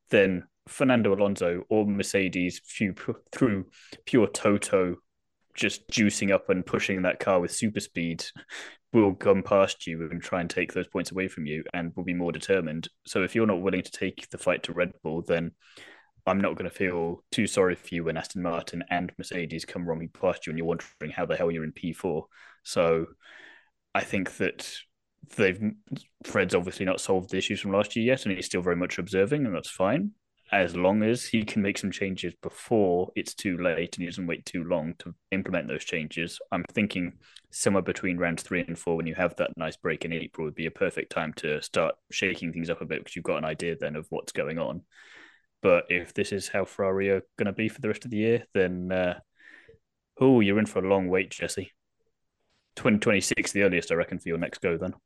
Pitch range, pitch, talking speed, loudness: 85-100 Hz, 90 Hz, 215 wpm, -28 LUFS